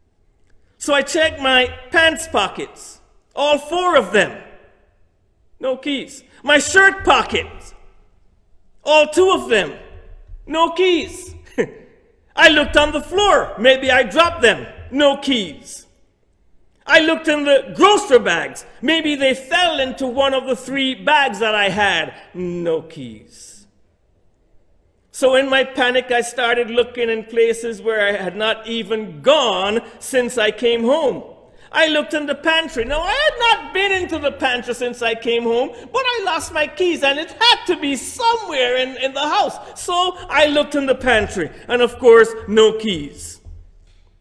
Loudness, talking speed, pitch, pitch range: -16 LUFS, 155 wpm, 265 Hz, 225-320 Hz